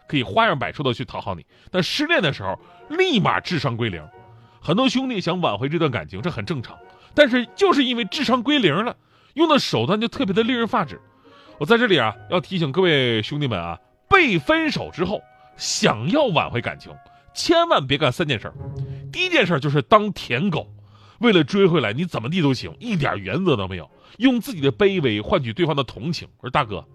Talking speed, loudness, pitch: 310 characters per minute, -20 LUFS, 170 Hz